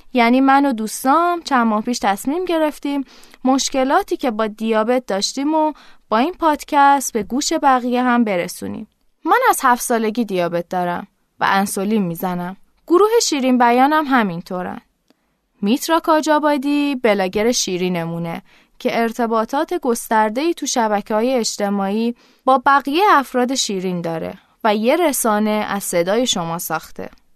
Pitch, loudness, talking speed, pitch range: 245 Hz, -17 LUFS, 130 wpm, 210-280 Hz